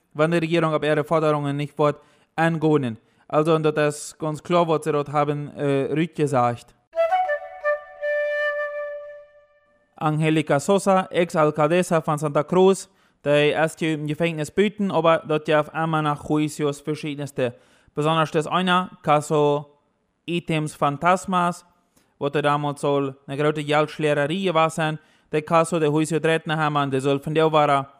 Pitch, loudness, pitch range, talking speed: 155 Hz, -22 LUFS, 150-170 Hz, 130 wpm